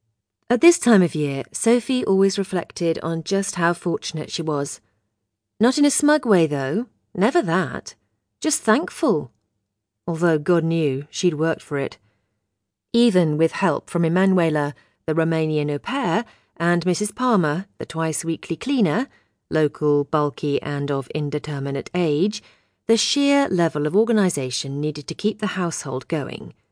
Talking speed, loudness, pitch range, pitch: 145 wpm, -21 LUFS, 145-200 Hz, 165 Hz